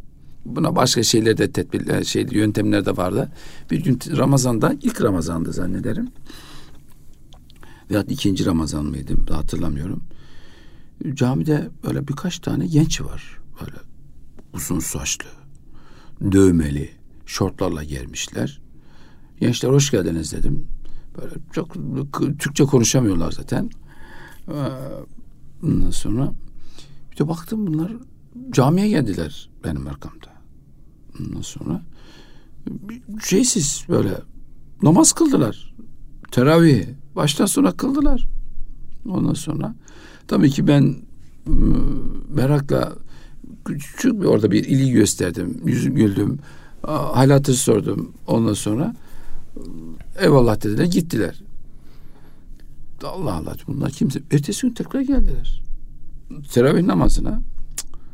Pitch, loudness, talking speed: 130 Hz, -20 LUFS, 95 wpm